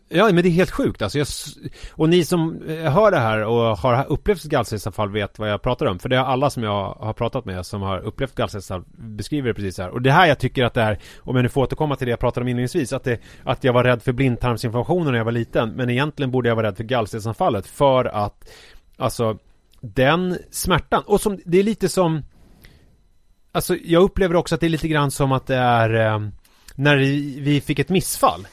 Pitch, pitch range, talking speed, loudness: 125 Hz, 110-145 Hz, 230 wpm, -20 LUFS